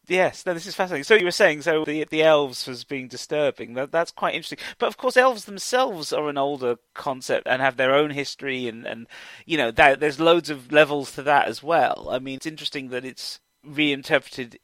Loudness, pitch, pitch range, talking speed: -22 LUFS, 150 Hz, 135-165 Hz, 220 wpm